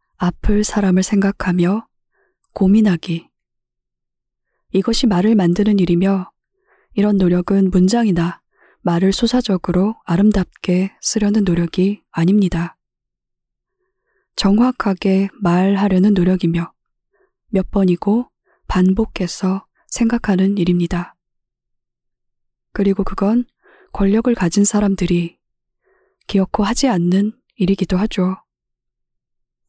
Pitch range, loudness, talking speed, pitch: 185-225 Hz, -17 LUFS, 220 characters per minute, 195 Hz